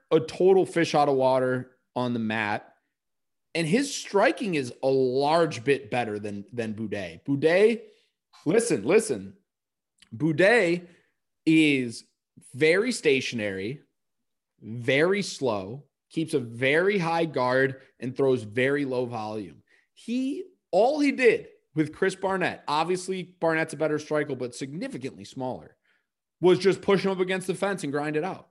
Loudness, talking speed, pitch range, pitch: -25 LUFS, 140 wpm, 125-185 Hz, 150 Hz